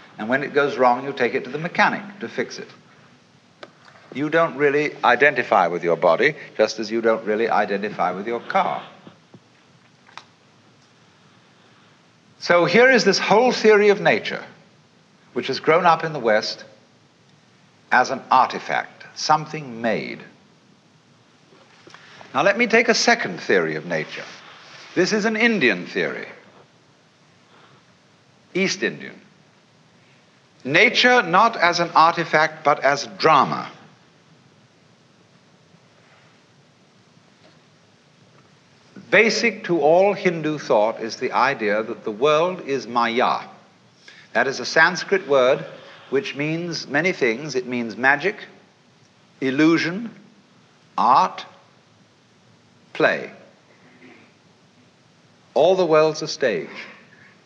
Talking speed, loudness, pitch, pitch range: 110 wpm, -19 LUFS, 165 Hz, 140-200 Hz